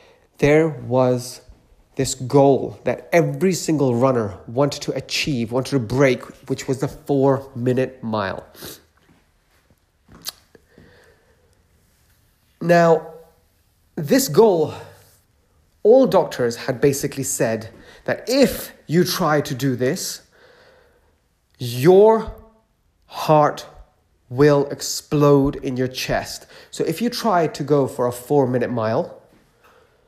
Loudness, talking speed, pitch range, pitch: -19 LUFS, 105 wpm, 120-160 Hz, 135 Hz